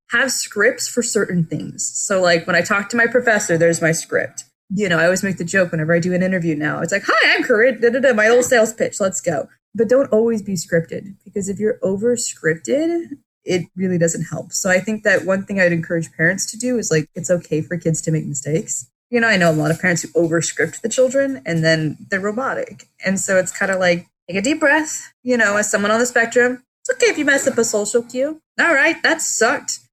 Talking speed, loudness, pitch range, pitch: 245 wpm, -18 LUFS, 170-240 Hz, 195 Hz